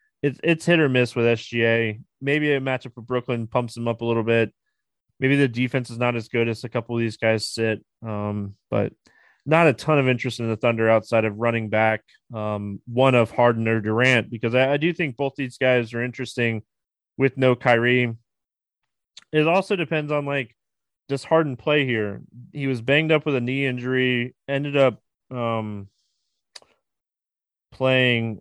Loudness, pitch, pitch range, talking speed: -22 LUFS, 125 Hz, 115-135 Hz, 180 wpm